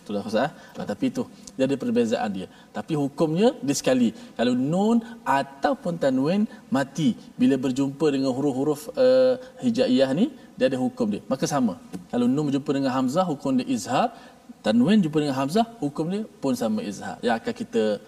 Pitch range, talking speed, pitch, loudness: 160-250 Hz, 160 wpm, 240 Hz, -24 LUFS